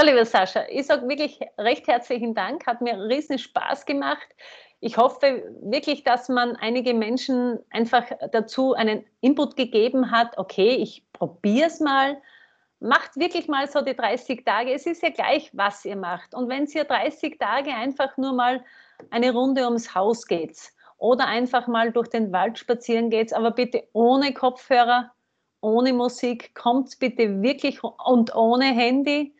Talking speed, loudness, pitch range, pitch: 160 wpm, -23 LUFS, 230-275 Hz, 250 Hz